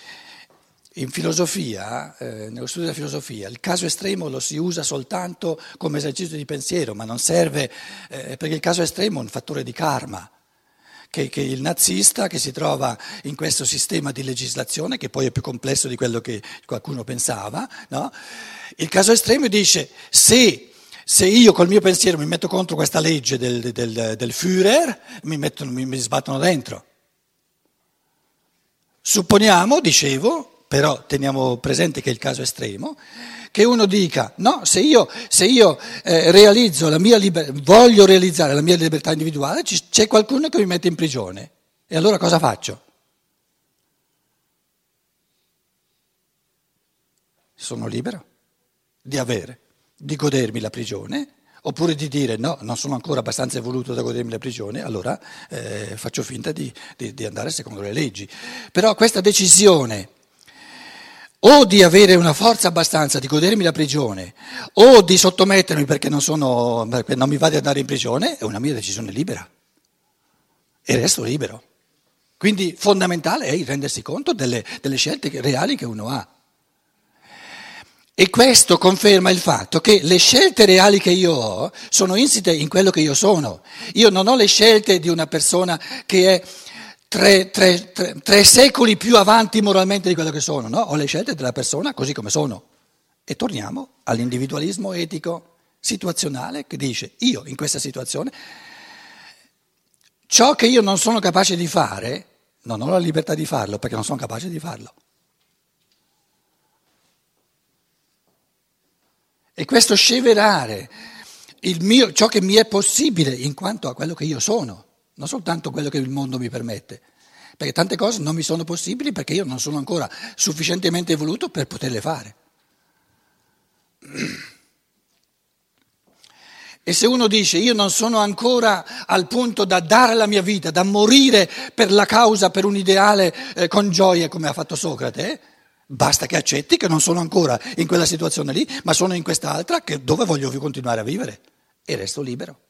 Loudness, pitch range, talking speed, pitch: -17 LUFS, 140-205 Hz, 160 wpm, 170 Hz